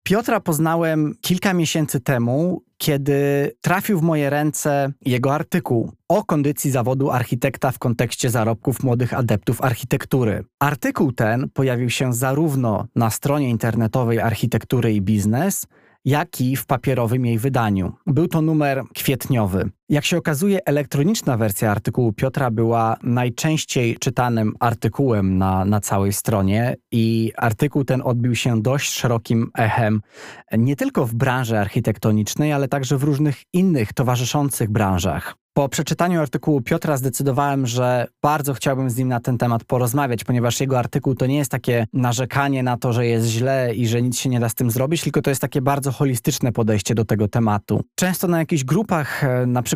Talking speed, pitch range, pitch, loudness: 155 wpm, 115-145 Hz, 130 Hz, -20 LUFS